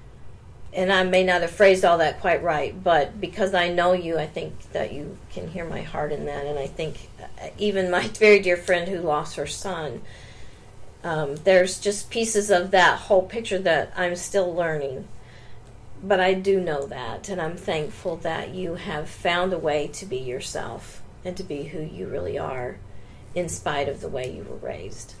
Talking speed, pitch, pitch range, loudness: 195 wpm, 175 Hz, 140-185 Hz, -24 LUFS